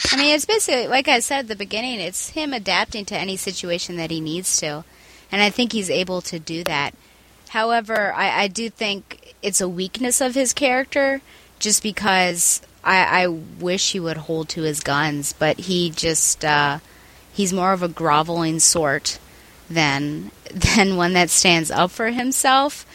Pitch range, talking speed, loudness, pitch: 165-230 Hz, 180 wpm, -19 LUFS, 185 Hz